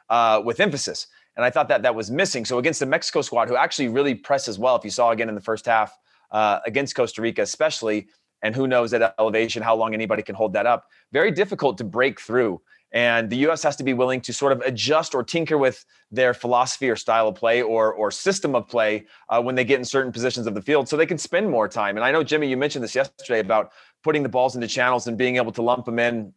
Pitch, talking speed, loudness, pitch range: 125 Hz, 255 wpm, -22 LUFS, 115-135 Hz